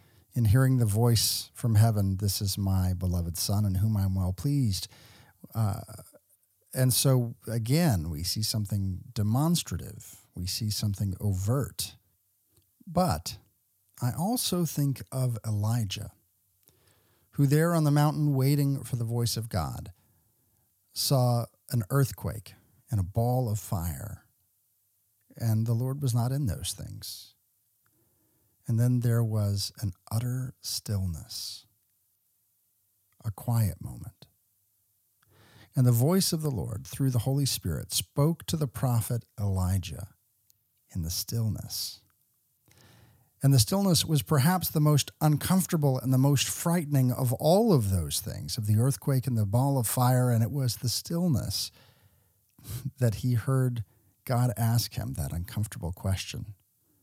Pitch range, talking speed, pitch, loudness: 100-130 Hz, 135 wpm, 110 Hz, -28 LUFS